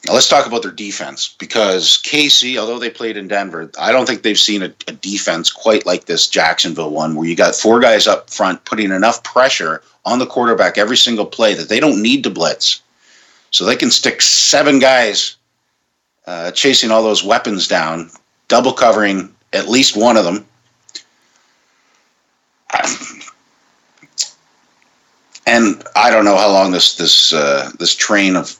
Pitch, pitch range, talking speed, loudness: 110 Hz, 95-130 Hz, 165 wpm, -12 LUFS